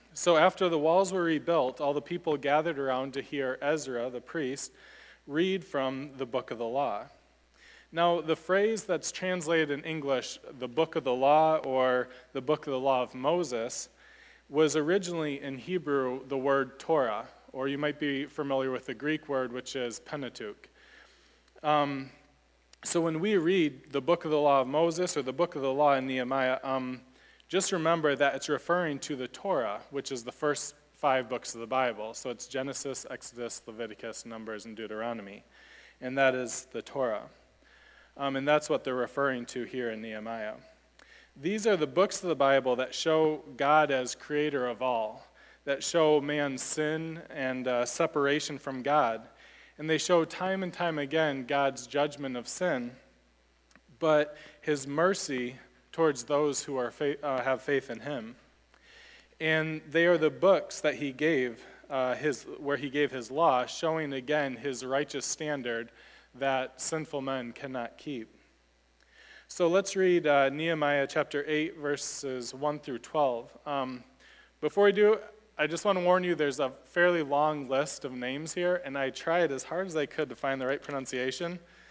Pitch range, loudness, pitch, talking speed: 130-160 Hz, -30 LUFS, 145 Hz, 175 wpm